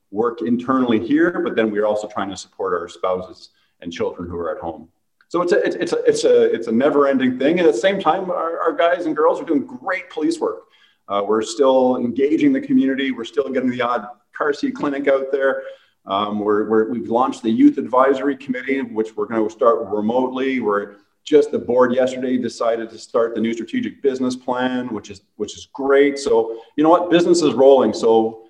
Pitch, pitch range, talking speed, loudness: 130 Hz, 115-170 Hz, 215 wpm, -19 LUFS